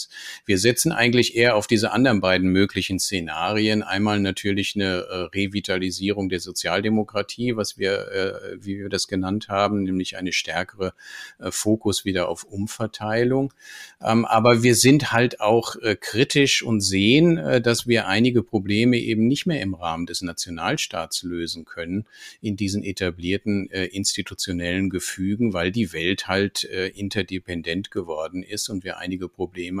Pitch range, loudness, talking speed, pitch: 95-115 Hz, -22 LUFS, 150 wpm, 100 Hz